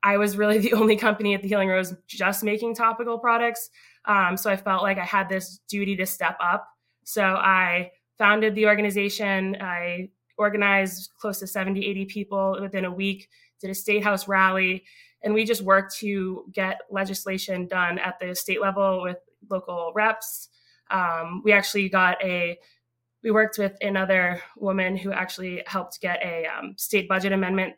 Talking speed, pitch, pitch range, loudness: 175 wpm, 195 Hz, 185-205 Hz, -24 LUFS